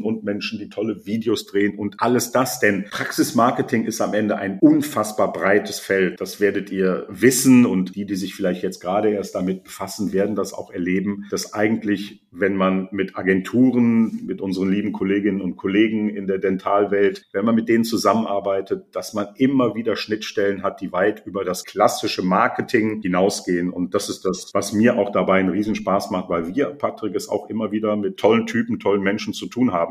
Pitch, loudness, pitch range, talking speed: 100 Hz, -21 LUFS, 95-110 Hz, 190 wpm